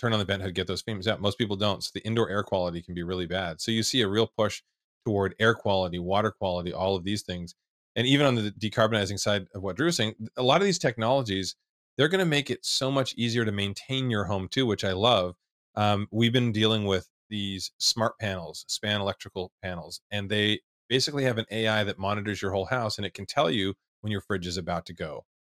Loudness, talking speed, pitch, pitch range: -27 LUFS, 240 wpm, 105 Hz, 95-115 Hz